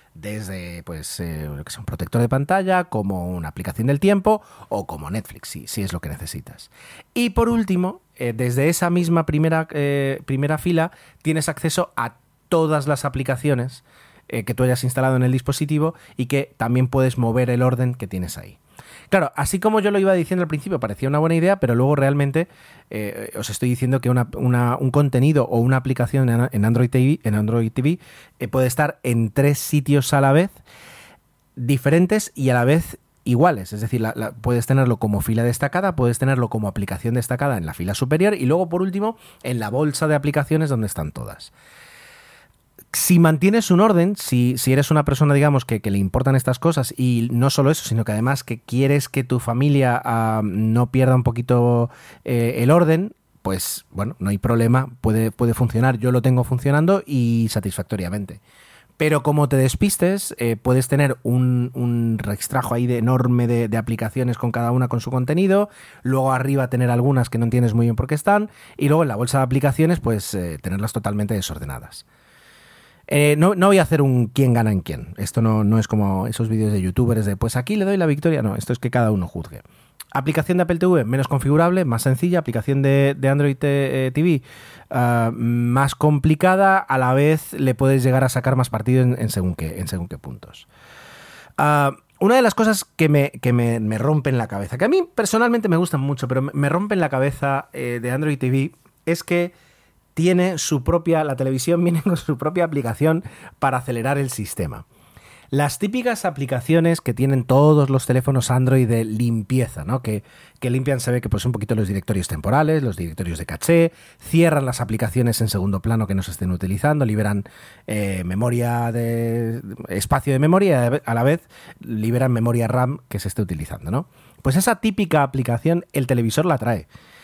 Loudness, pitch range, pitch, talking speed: -20 LUFS, 115-150 Hz, 130 Hz, 190 wpm